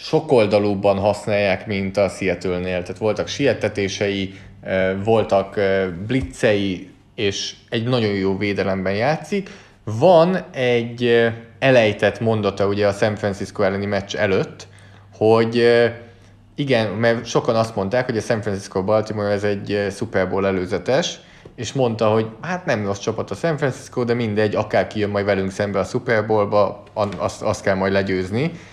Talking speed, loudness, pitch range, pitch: 140 wpm, -20 LUFS, 100-115 Hz, 105 Hz